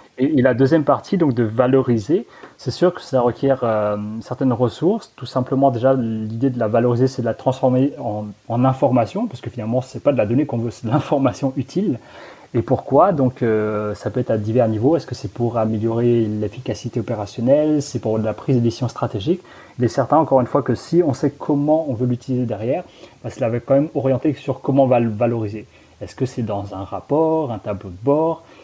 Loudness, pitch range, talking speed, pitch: -19 LUFS, 115-135 Hz, 220 wpm, 125 Hz